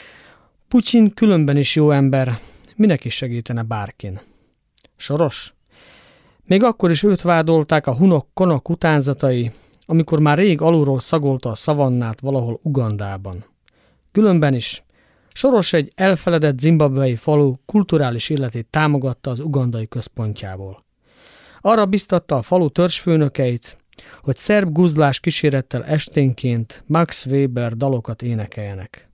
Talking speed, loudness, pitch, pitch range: 115 wpm, -18 LUFS, 140 Hz, 120-165 Hz